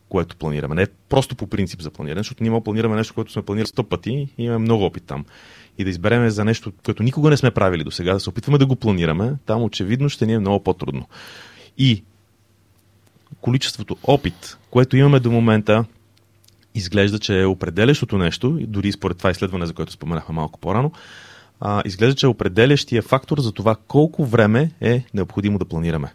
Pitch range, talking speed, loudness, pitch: 100-120 Hz, 190 wpm, -20 LUFS, 110 Hz